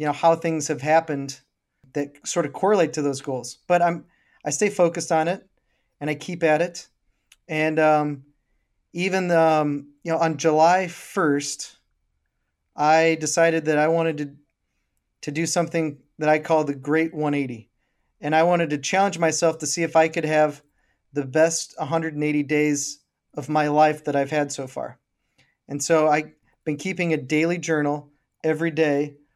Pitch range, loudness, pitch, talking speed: 145-165 Hz, -22 LUFS, 155 Hz, 170 wpm